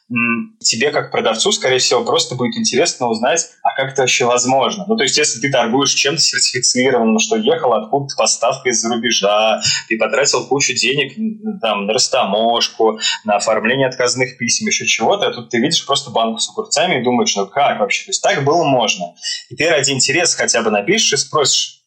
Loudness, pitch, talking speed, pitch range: -15 LUFS, 130 Hz, 185 wpm, 115-165 Hz